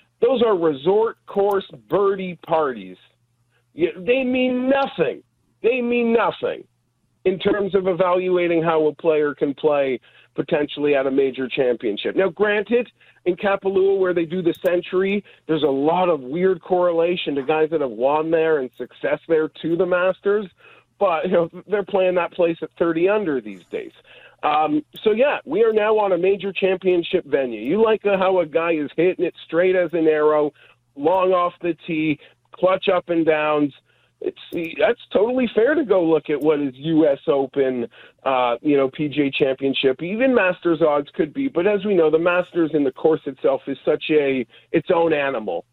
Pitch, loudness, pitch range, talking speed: 170 Hz, -20 LUFS, 150-195 Hz, 175 wpm